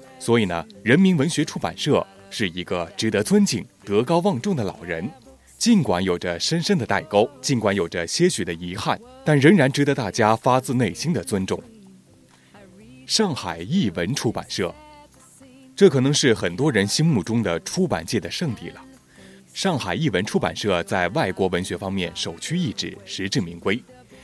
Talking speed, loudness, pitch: 255 characters per minute, -22 LUFS, 120 Hz